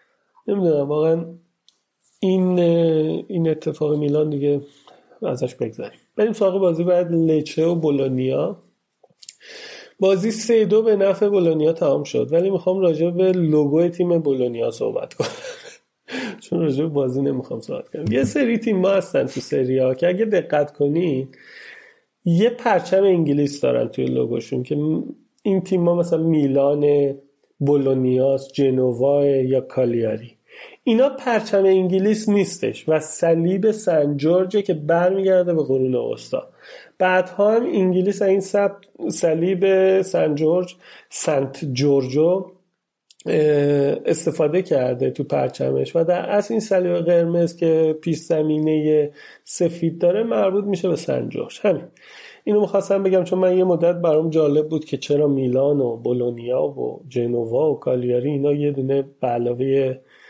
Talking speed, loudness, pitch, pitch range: 135 wpm, -20 LUFS, 170 Hz, 145-195 Hz